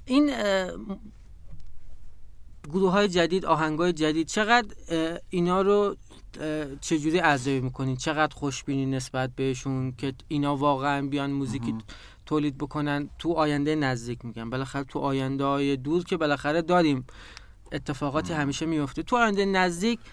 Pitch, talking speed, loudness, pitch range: 150 Hz, 125 wpm, -26 LUFS, 135-170 Hz